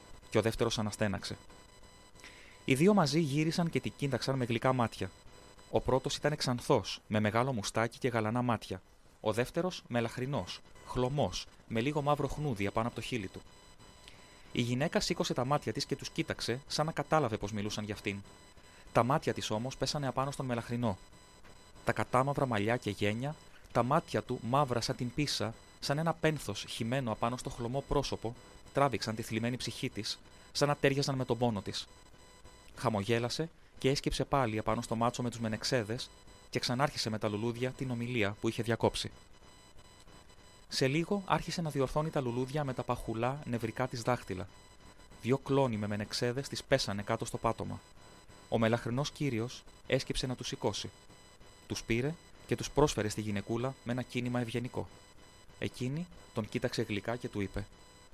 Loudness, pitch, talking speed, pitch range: -34 LUFS, 115 Hz, 165 wpm, 100-135 Hz